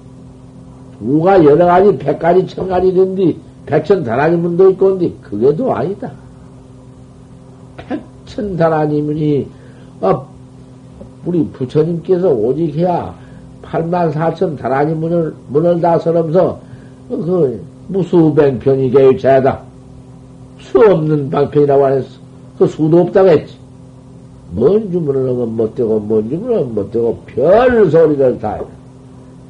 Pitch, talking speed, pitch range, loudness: 150 Hz, 245 characters per minute, 130-175 Hz, -13 LUFS